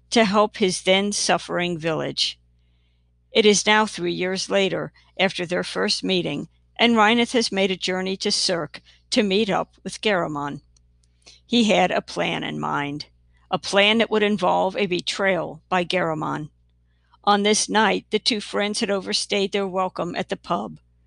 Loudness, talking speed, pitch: -21 LUFS, 160 wpm, 185 Hz